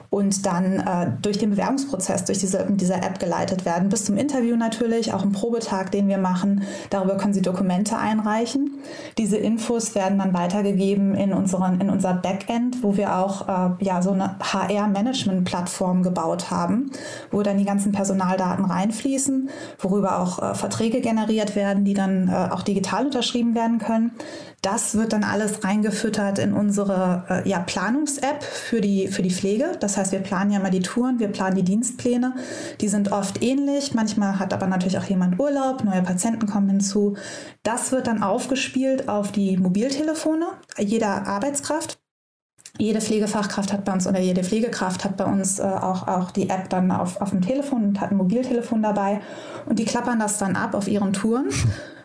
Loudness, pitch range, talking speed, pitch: -23 LUFS, 195-235 Hz, 180 wpm, 205 Hz